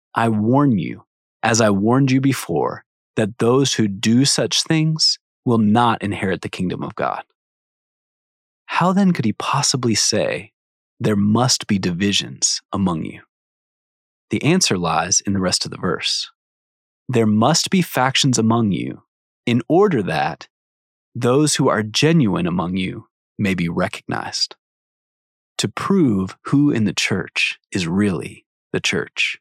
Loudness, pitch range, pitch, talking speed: -18 LUFS, 105-140 Hz, 115 Hz, 145 wpm